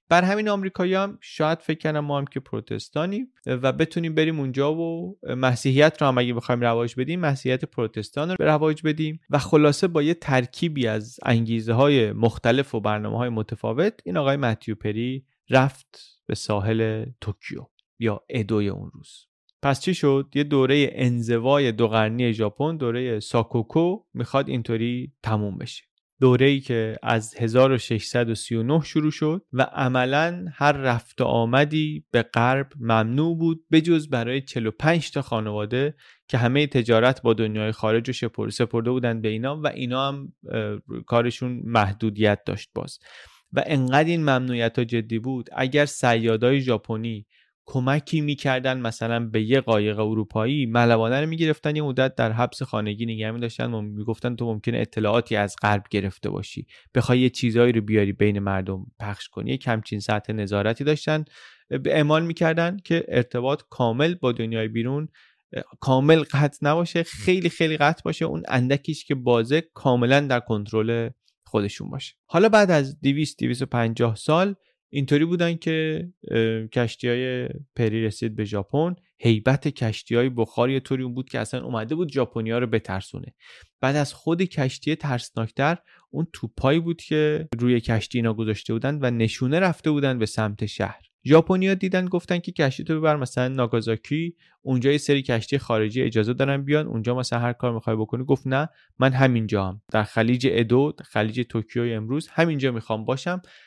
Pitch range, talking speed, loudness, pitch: 115-150 Hz, 155 wpm, -23 LUFS, 130 Hz